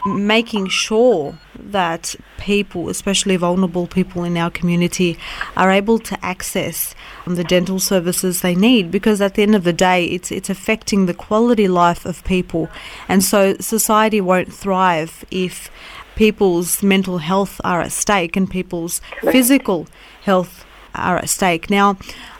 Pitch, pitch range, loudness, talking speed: 190 Hz, 180-205 Hz, -17 LUFS, 145 wpm